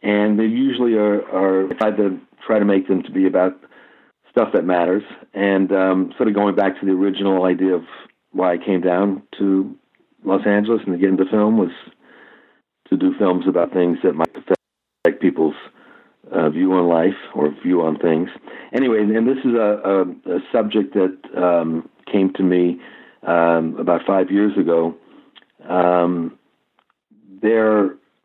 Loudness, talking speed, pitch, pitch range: -18 LUFS, 170 wpm, 95 Hz, 90-105 Hz